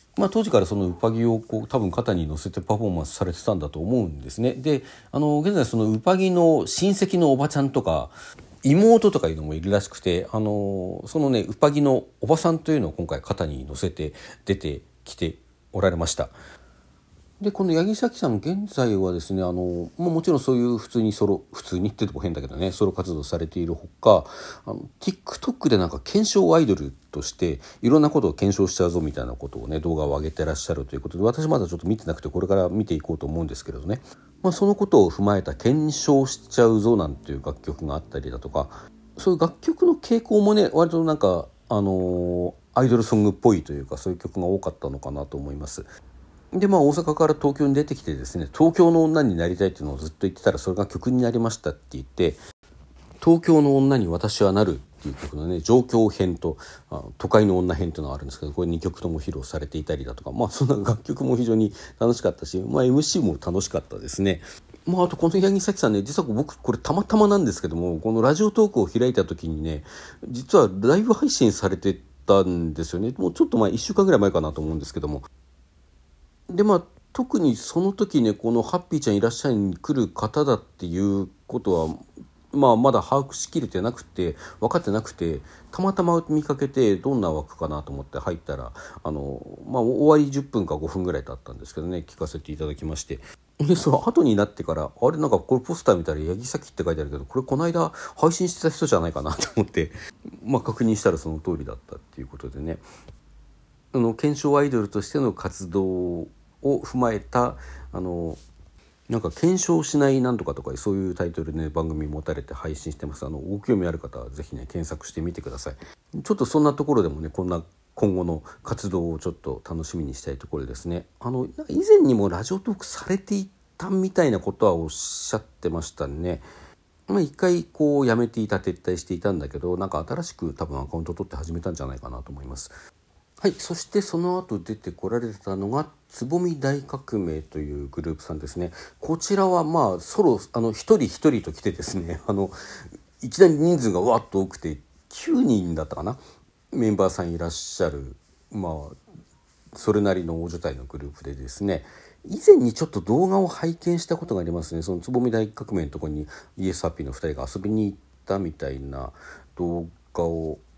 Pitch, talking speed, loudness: 95 Hz, 415 characters per minute, -23 LUFS